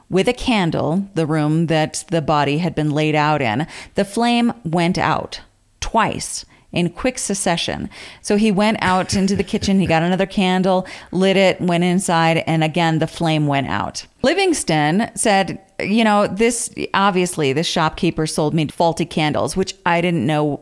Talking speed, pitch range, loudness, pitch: 170 wpm, 155-195 Hz, -18 LUFS, 170 Hz